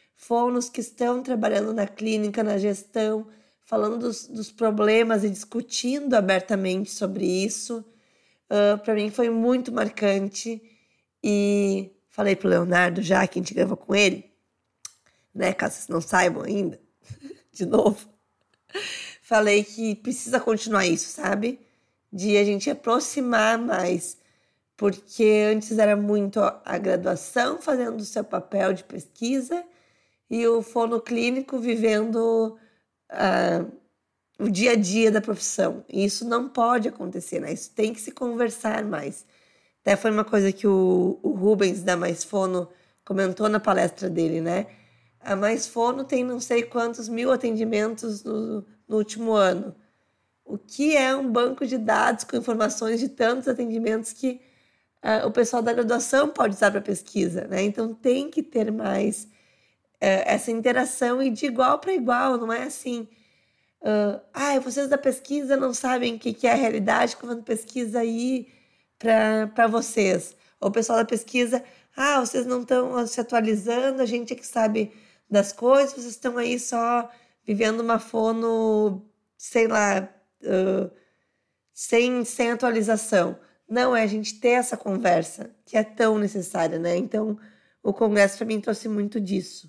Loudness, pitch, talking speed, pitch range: -24 LUFS, 220 Hz, 150 wpm, 205-240 Hz